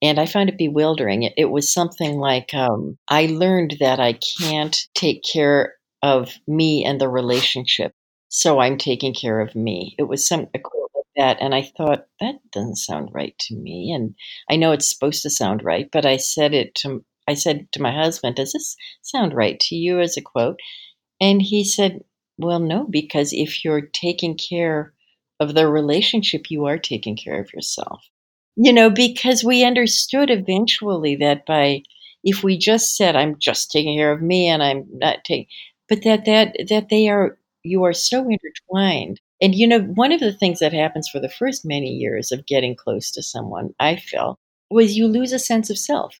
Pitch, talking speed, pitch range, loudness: 155 Hz, 195 wpm, 140-200 Hz, -19 LUFS